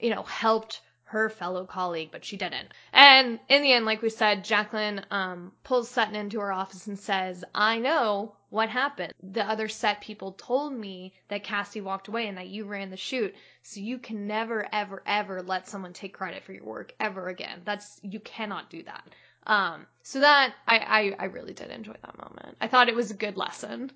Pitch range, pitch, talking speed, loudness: 195-225 Hz, 210 Hz, 210 wpm, -25 LUFS